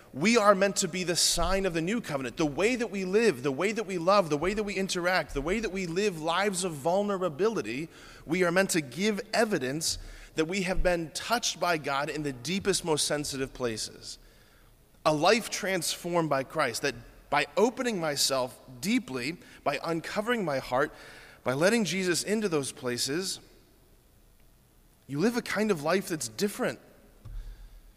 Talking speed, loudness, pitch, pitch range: 175 wpm, -28 LUFS, 175 Hz, 140-195 Hz